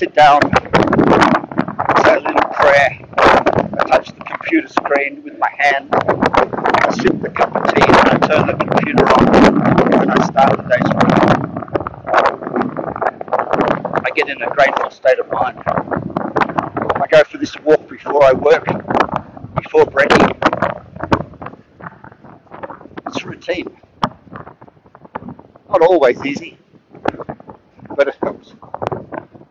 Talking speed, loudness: 120 wpm, -14 LUFS